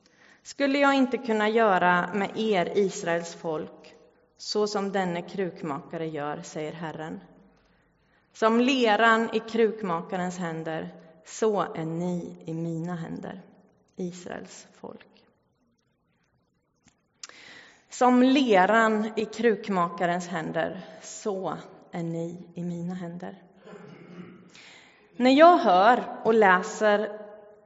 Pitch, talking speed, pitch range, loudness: 185 Hz, 100 wpm, 170-215 Hz, -25 LUFS